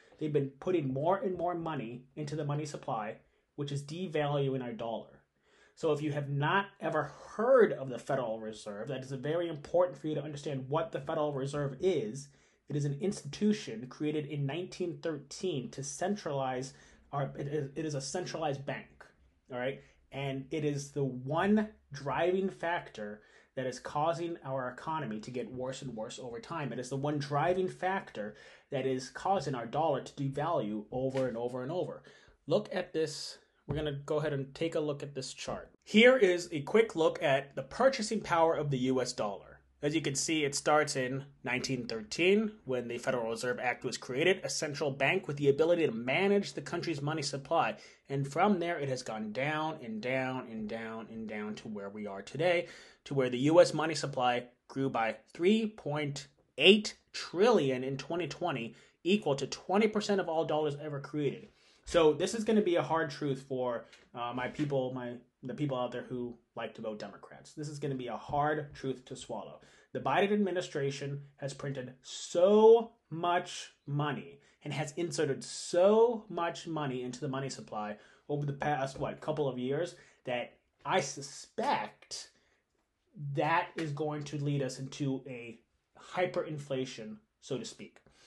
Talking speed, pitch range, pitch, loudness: 175 wpm, 130-165 Hz, 145 Hz, -33 LUFS